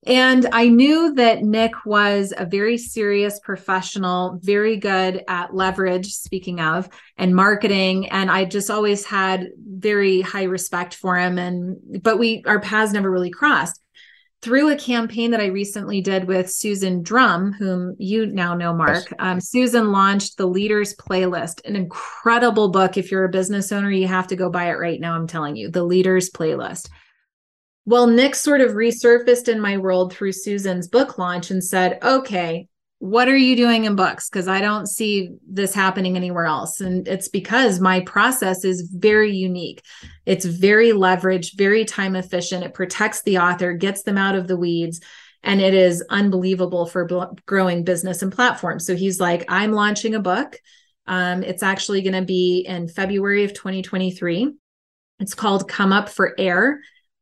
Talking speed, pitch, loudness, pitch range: 175 wpm, 195 Hz, -19 LUFS, 185-210 Hz